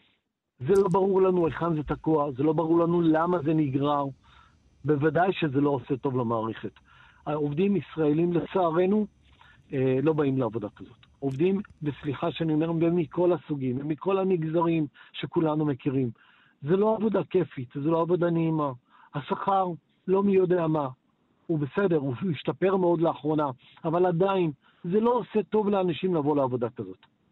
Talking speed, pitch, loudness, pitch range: 145 wpm, 160 Hz, -26 LUFS, 145-180 Hz